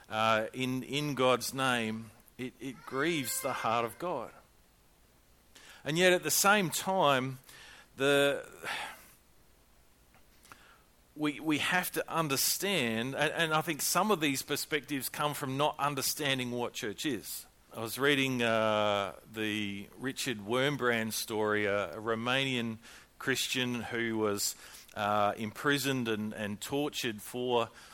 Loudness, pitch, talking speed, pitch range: -31 LUFS, 125 Hz, 125 wpm, 110-140 Hz